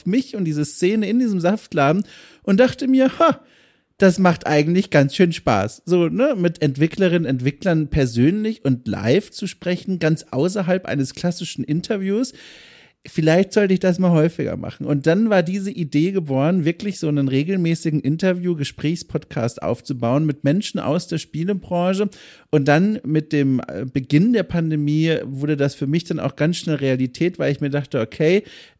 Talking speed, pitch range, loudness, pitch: 160 wpm, 145-190 Hz, -20 LUFS, 165 Hz